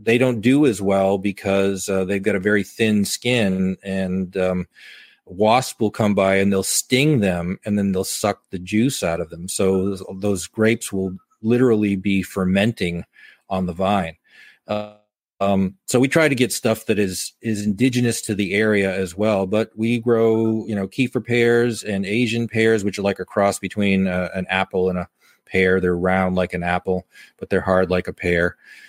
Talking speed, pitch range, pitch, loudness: 195 wpm, 95-110 Hz, 100 Hz, -20 LUFS